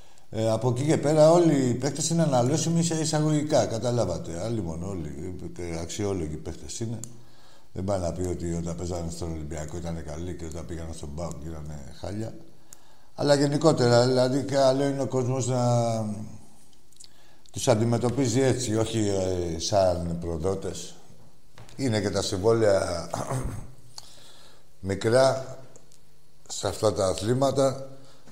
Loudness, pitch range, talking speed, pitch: -26 LUFS, 85-130 Hz, 125 wpm, 110 Hz